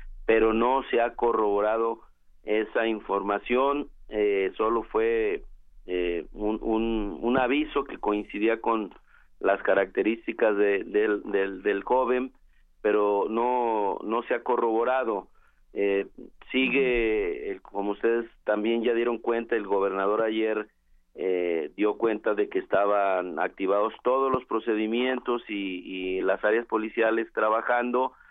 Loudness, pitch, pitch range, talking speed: -26 LUFS, 115 Hz, 105-130 Hz, 125 wpm